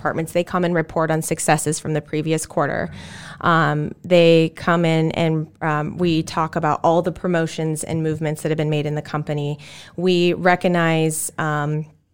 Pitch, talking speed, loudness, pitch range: 160 Hz, 170 wpm, -20 LUFS, 155-170 Hz